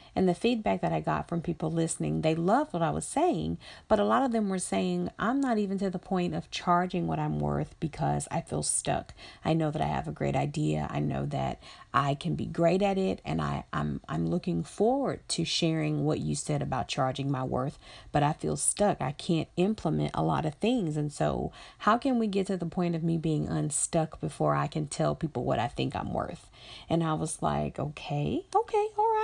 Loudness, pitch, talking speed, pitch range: -30 LUFS, 165 Hz, 230 wpm, 125-190 Hz